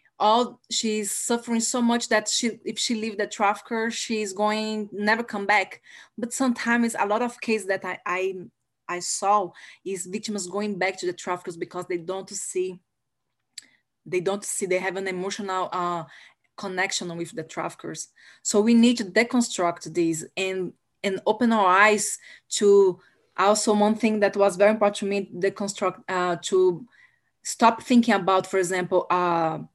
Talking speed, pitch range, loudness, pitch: 165 wpm, 185-220 Hz, -24 LUFS, 200 Hz